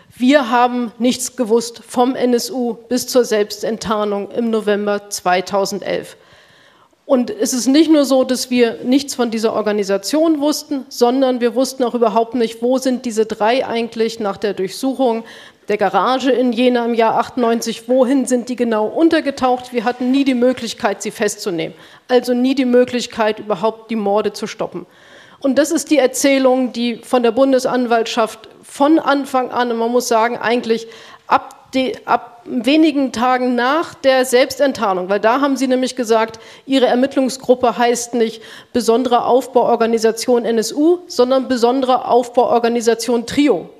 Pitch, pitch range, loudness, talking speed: 245 Hz, 225-260 Hz, -16 LUFS, 150 wpm